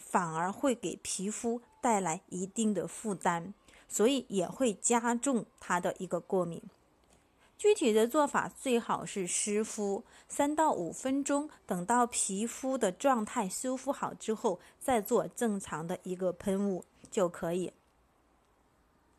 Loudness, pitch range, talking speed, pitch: -32 LUFS, 190-250 Hz, 200 characters per minute, 220 Hz